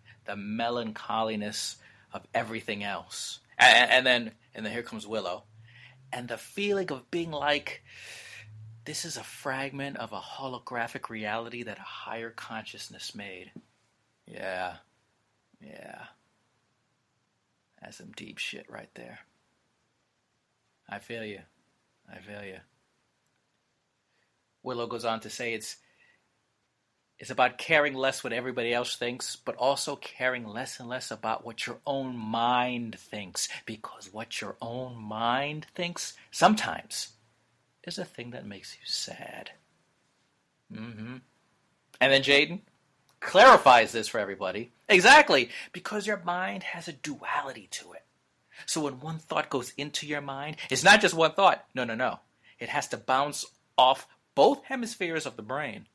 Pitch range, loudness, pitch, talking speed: 110-145 Hz, -26 LUFS, 125 Hz, 140 wpm